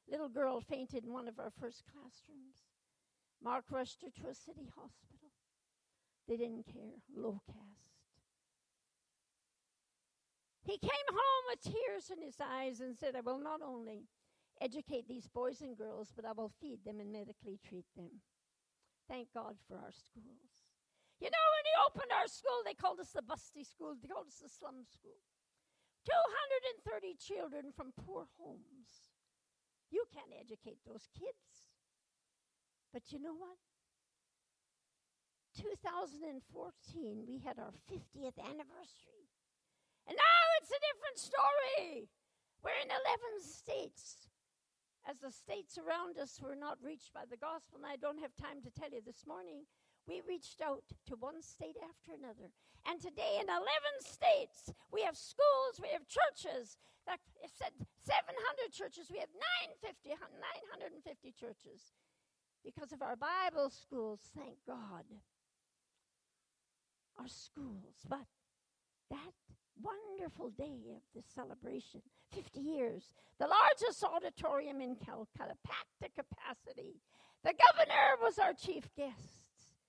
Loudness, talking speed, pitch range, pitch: -38 LUFS, 140 wpm, 250-335 Hz, 285 Hz